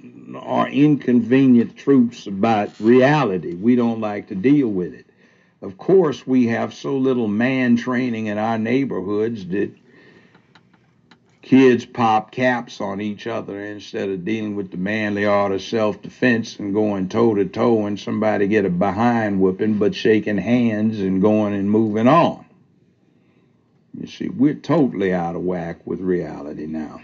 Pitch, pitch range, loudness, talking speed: 110 Hz, 100-120 Hz, -19 LUFS, 150 wpm